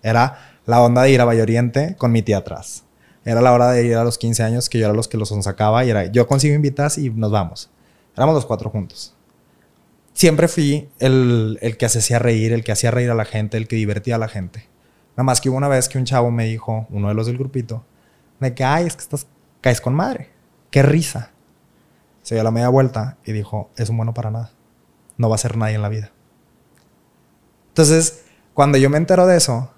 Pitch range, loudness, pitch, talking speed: 110-135 Hz, -17 LUFS, 120 Hz, 230 wpm